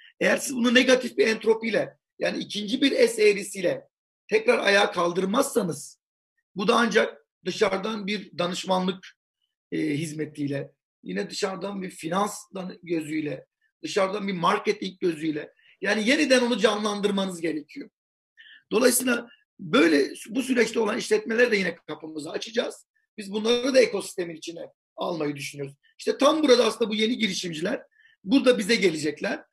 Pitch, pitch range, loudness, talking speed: 210 Hz, 180-250 Hz, -24 LUFS, 130 wpm